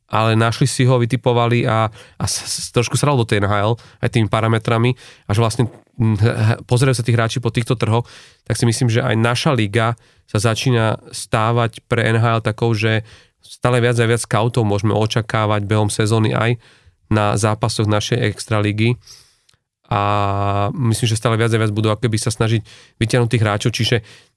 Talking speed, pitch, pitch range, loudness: 170 wpm, 115 Hz, 110-120 Hz, -18 LUFS